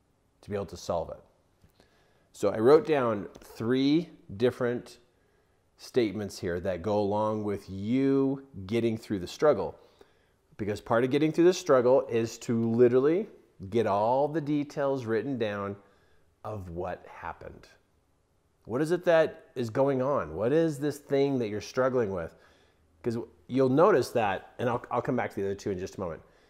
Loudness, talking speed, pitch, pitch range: -28 LUFS, 170 wpm, 120 Hz, 100-135 Hz